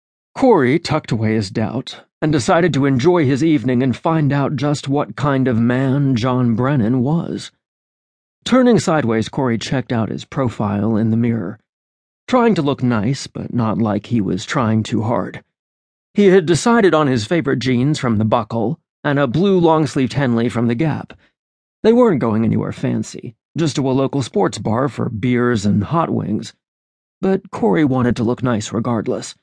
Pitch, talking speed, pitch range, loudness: 130 Hz, 175 wpm, 115-155 Hz, -17 LUFS